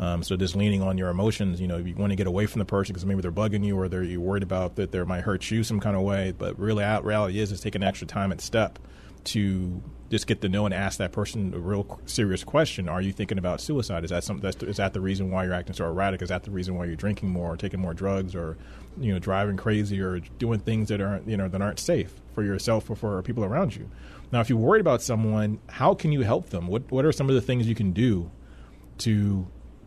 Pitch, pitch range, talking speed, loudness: 100 Hz, 95-105 Hz, 270 wpm, -27 LUFS